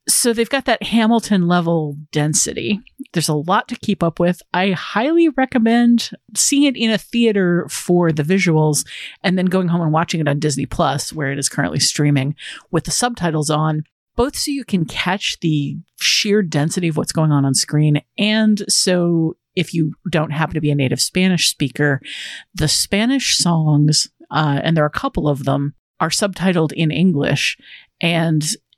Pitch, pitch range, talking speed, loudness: 170 Hz, 150-205 Hz, 180 wpm, -17 LUFS